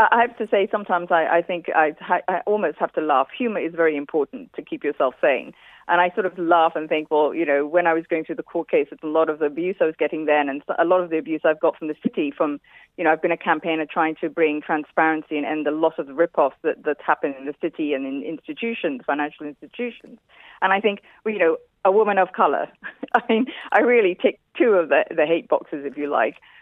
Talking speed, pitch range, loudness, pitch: 255 wpm, 155-210 Hz, -22 LUFS, 170 Hz